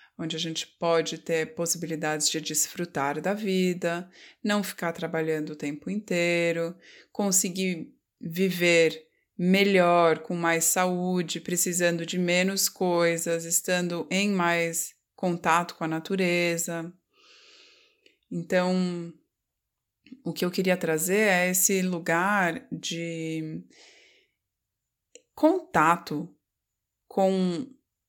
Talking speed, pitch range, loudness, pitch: 95 wpm, 165-195 Hz, -26 LUFS, 175 Hz